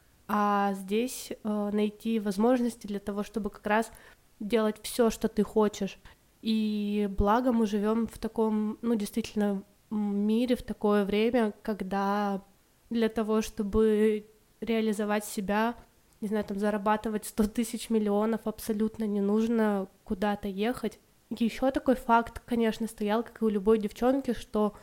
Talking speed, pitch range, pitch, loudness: 135 wpm, 210-225 Hz, 215 Hz, -29 LUFS